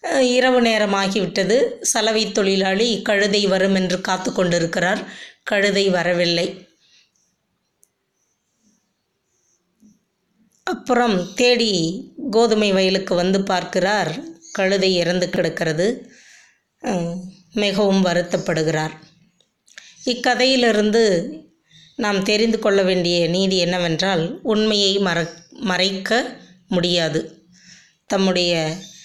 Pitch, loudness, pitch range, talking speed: 190 Hz, -19 LUFS, 175-215 Hz, 70 wpm